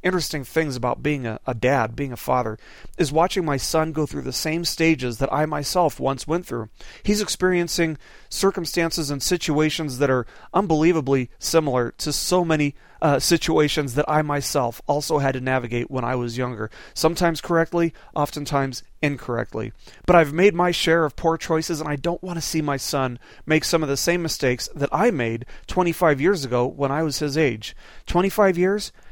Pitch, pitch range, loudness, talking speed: 150 Hz, 135-165 Hz, -22 LUFS, 185 wpm